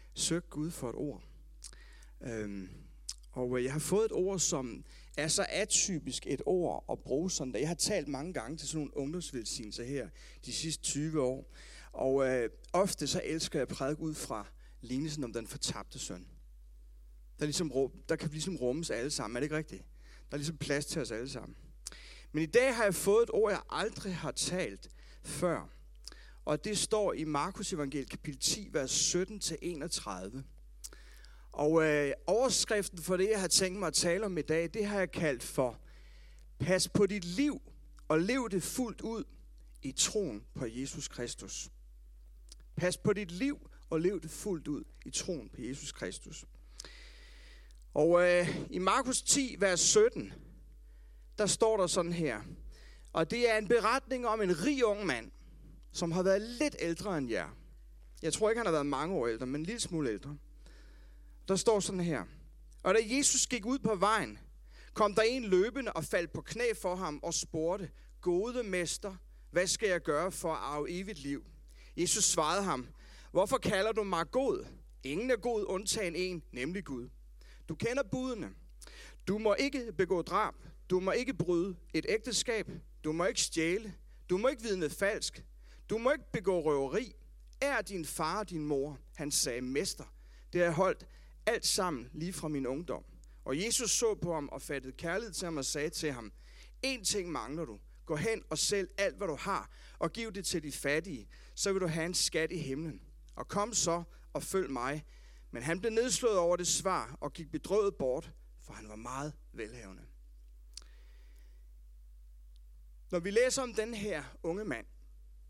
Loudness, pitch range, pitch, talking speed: -33 LUFS, 135-200 Hz, 165 Hz, 180 wpm